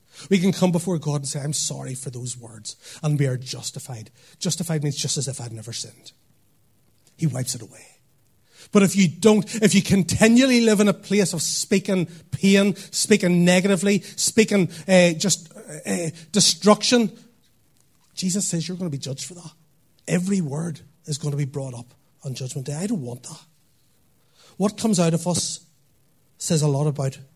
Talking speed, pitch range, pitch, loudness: 180 wpm, 140-190 Hz, 160 Hz, -21 LUFS